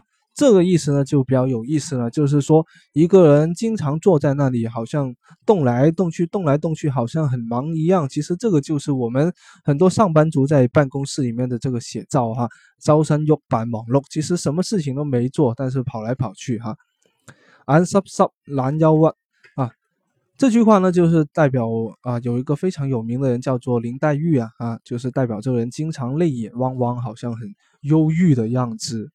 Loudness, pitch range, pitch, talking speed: -19 LUFS, 125-160 Hz, 140 Hz, 290 characters per minute